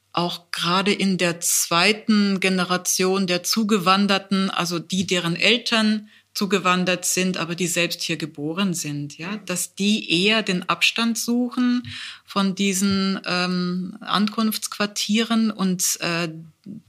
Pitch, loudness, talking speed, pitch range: 190 Hz, -21 LUFS, 115 wpm, 175-210 Hz